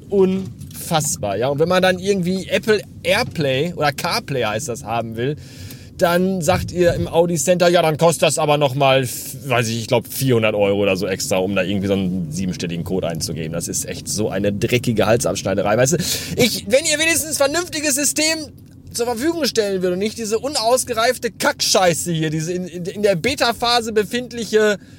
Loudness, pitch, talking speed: -18 LUFS, 170 Hz, 180 wpm